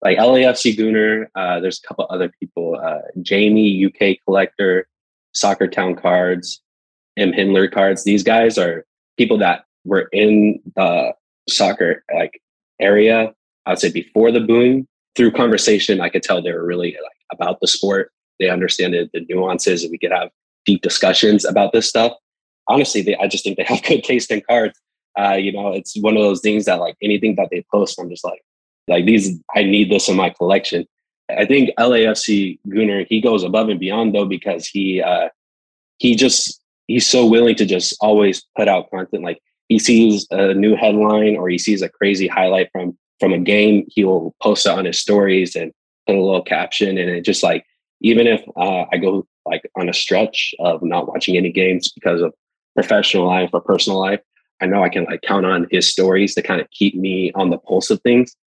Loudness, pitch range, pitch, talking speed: -16 LUFS, 95-110 Hz, 100 Hz, 200 wpm